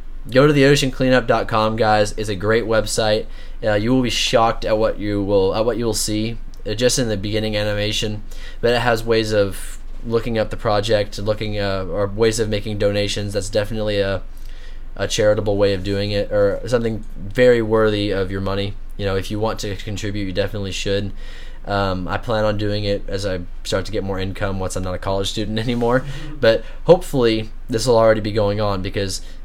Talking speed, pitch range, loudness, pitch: 205 wpm, 100-110 Hz, -19 LUFS, 105 Hz